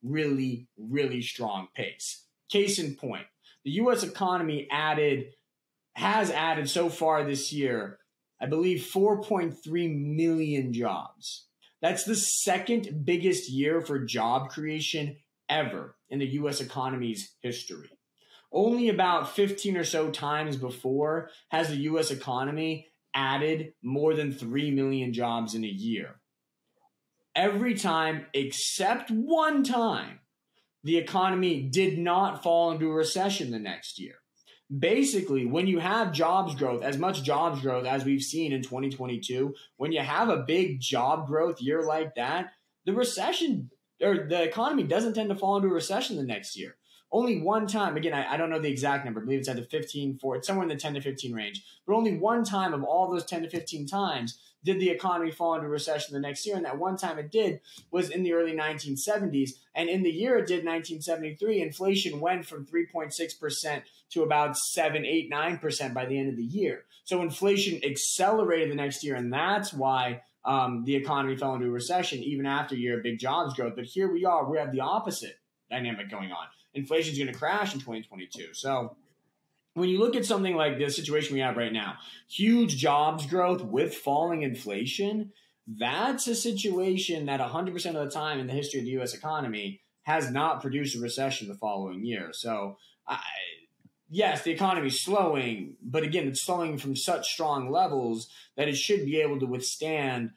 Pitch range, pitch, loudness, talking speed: 135-180 Hz, 155 Hz, -29 LUFS, 175 wpm